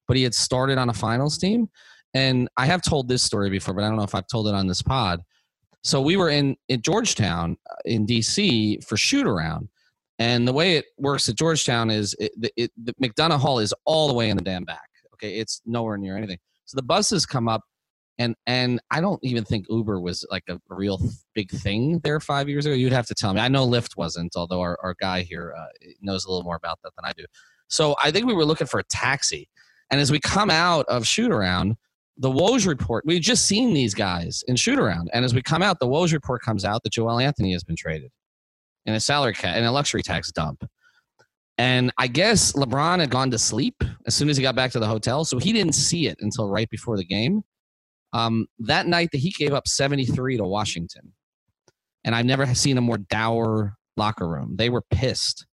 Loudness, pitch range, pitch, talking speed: -22 LUFS, 105-140 Hz, 120 Hz, 230 wpm